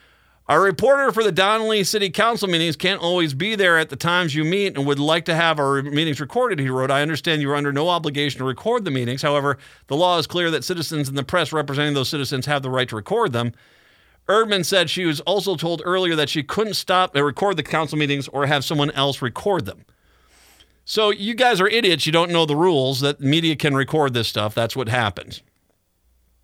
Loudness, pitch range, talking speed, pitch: -20 LUFS, 140-185 Hz, 220 wpm, 155 Hz